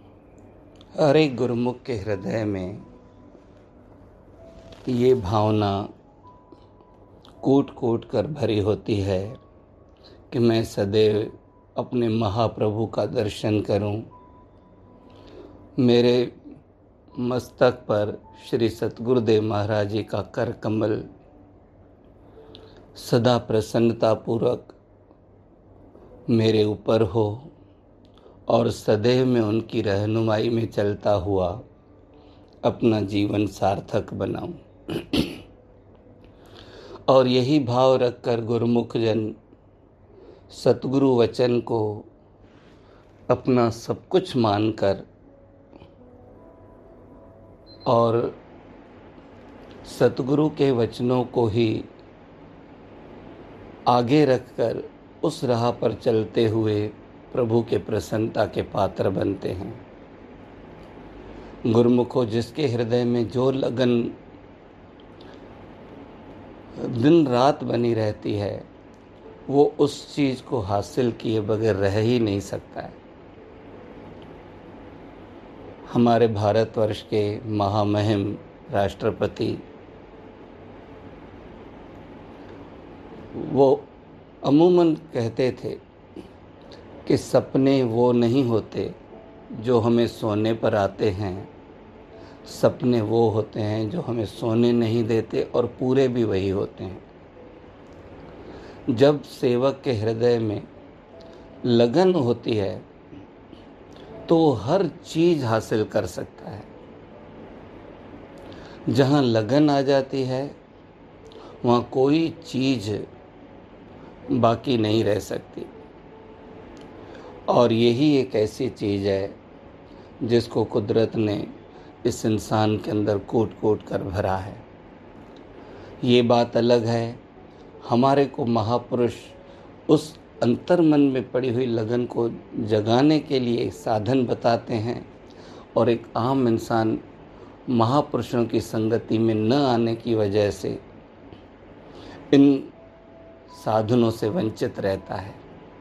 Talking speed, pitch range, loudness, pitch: 95 wpm, 105-125 Hz, -23 LUFS, 115 Hz